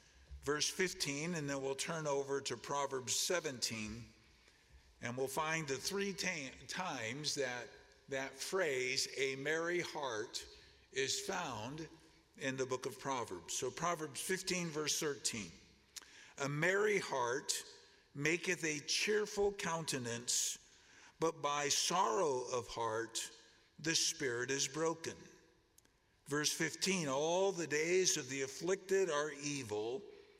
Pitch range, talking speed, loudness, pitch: 135-185 Hz, 120 wpm, -38 LUFS, 155 Hz